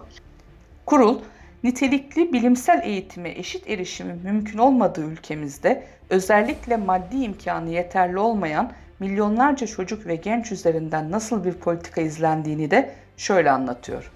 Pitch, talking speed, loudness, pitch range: 210 Hz, 110 wpm, -22 LUFS, 175-245 Hz